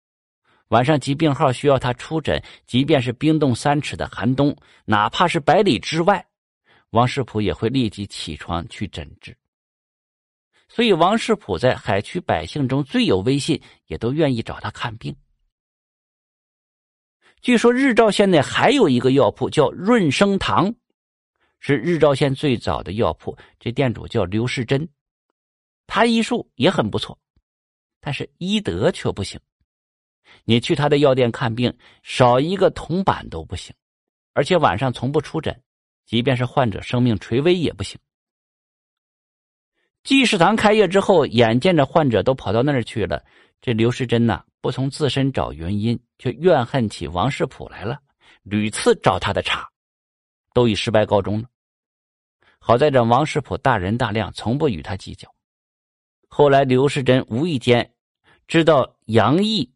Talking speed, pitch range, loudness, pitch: 225 characters per minute, 110-155 Hz, -19 LUFS, 125 Hz